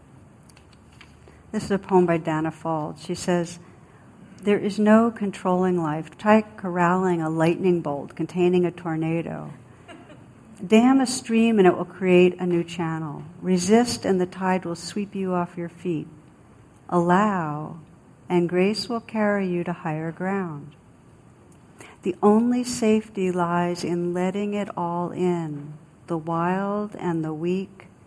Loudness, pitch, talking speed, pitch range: -23 LUFS, 180 Hz, 140 wpm, 165-195 Hz